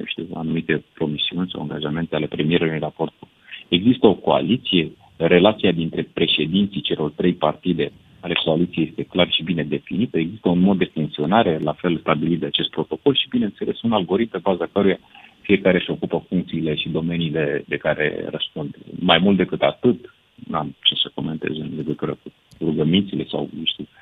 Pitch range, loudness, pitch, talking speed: 80-90 Hz, -21 LUFS, 85 Hz, 165 wpm